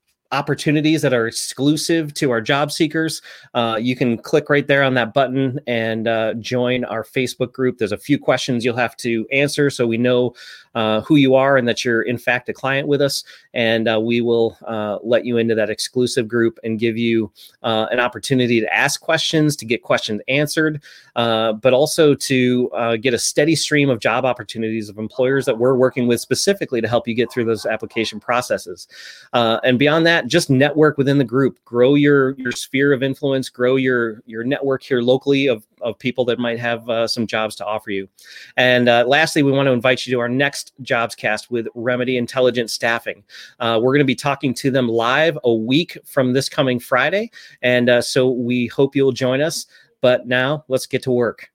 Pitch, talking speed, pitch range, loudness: 125 Hz, 205 wpm, 115-140 Hz, -18 LUFS